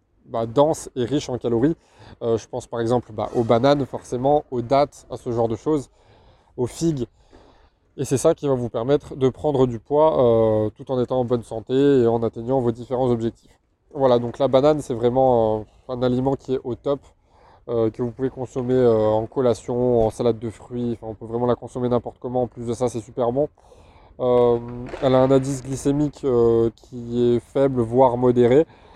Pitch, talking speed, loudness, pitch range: 125 Hz, 205 wpm, -21 LUFS, 115-135 Hz